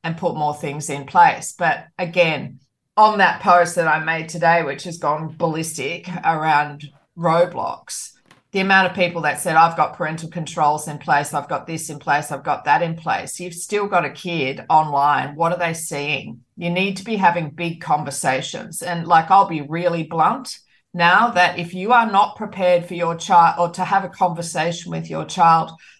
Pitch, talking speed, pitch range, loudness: 170 Hz, 195 wpm, 150-180 Hz, -19 LUFS